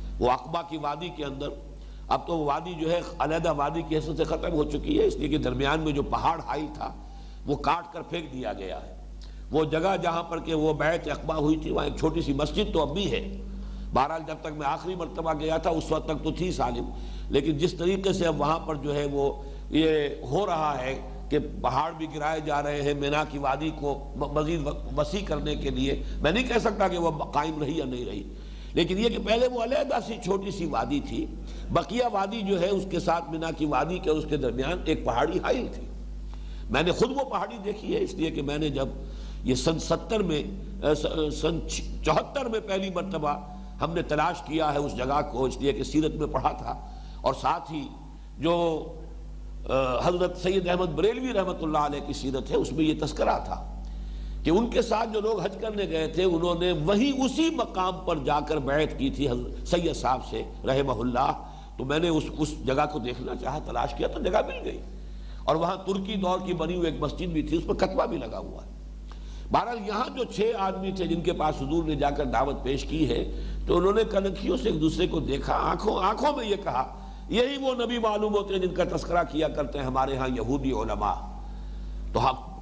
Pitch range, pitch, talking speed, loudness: 145-185 Hz, 160 Hz, 220 wpm, -28 LUFS